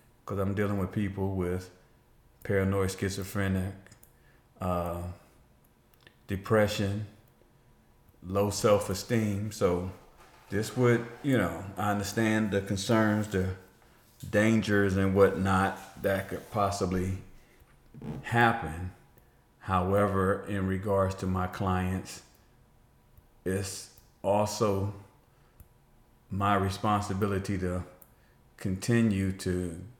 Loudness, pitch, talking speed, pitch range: -29 LUFS, 100 Hz, 85 wpm, 95-110 Hz